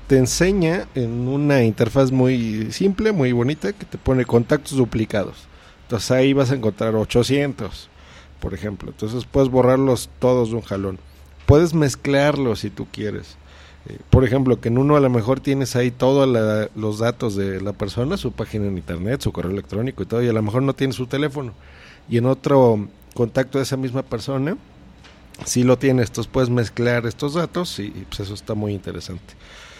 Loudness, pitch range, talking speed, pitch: -20 LUFS, 105-135 Hz, 185 wpm, 120 Hz